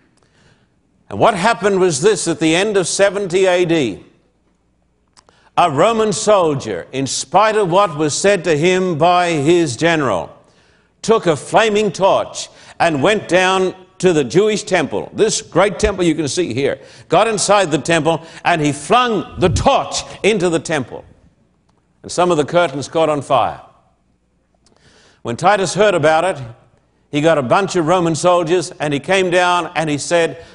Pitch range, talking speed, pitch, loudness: 150-195 Hz, 160 wpm, 175 Hz, -15 LUFS